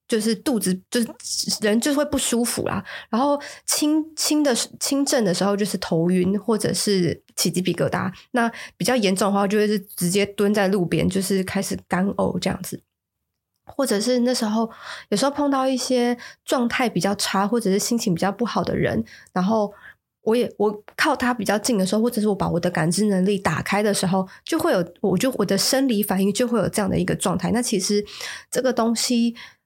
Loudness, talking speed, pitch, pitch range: -22 LUFS, 295 characters per minute, 210 Hz, 195-245 Hz